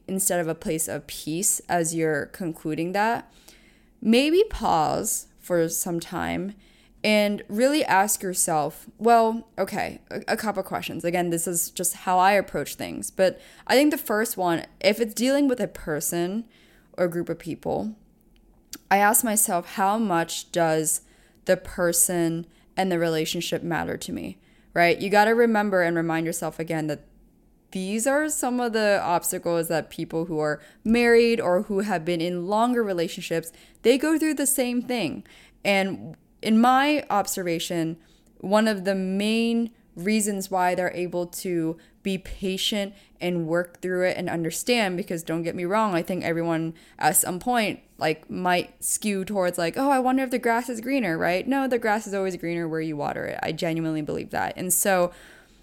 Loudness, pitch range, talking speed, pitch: -24 LUFS, 170-220 Hz, 170 wpm, 185 Hz